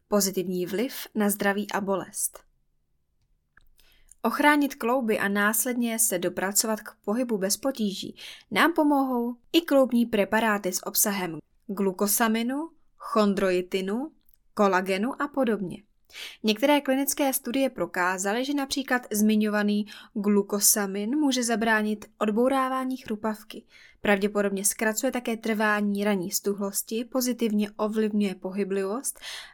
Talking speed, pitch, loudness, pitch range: 100 wpm, 215 Hz, -25 LUFS, 200-255 Hz